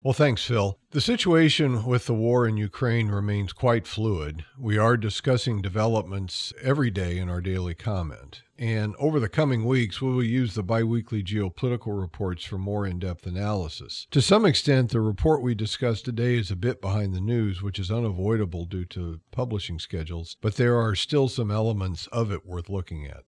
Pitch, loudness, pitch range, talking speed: 110 Hz, -26 LUFS, 95-120 Hz, 185 wpm